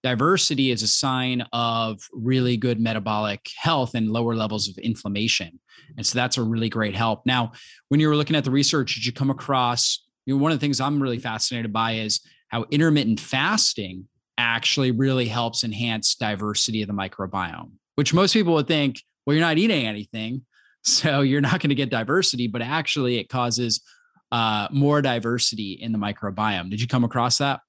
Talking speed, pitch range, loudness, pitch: 190 wpm, 110-140 Hz, -22 LUFS, 120 Hz